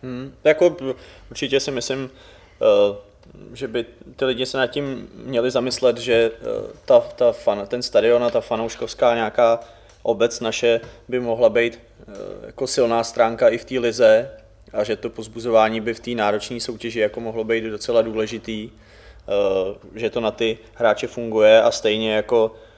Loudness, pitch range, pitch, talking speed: -20 LUFS, 110-130 Hz, 115 Hz, 135 wpm